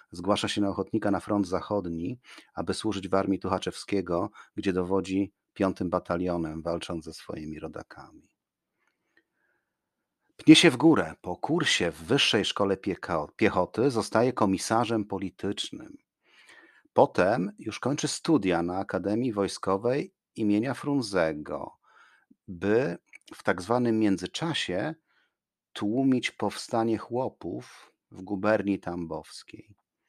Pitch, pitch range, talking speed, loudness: 100 Hz, 90-110 Hz, 105 wpm, -27 LUFS